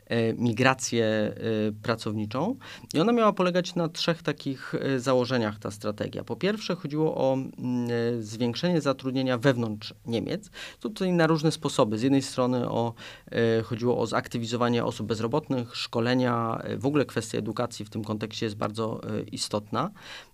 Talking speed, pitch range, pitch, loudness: 130 wpm, 115-145 Hz, 120 Hz, -27 LUFS